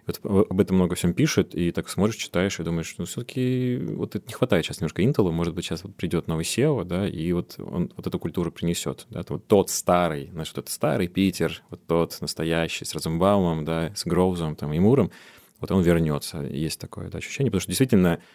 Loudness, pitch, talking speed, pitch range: -25 LUFS, 90 Hz, 220 wpm, 80-100 Hz